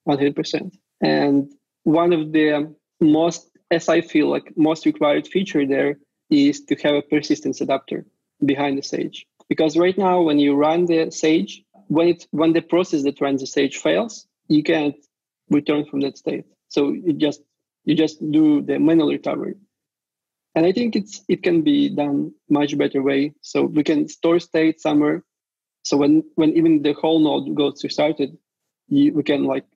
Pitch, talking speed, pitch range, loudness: 155 Hz, 175 wpm, 145-175 Hz, -20 LUFS